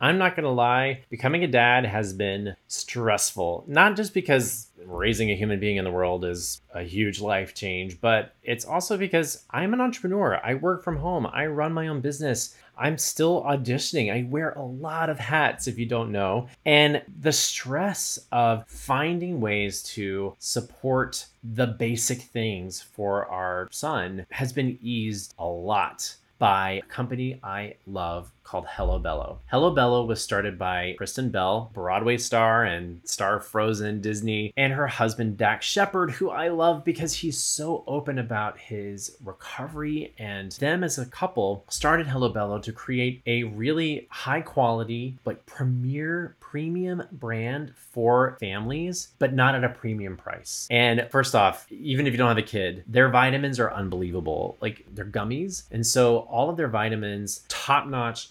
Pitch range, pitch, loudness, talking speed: 105-145 Hz, 120 Hz, -25 LUFS, 165 wpm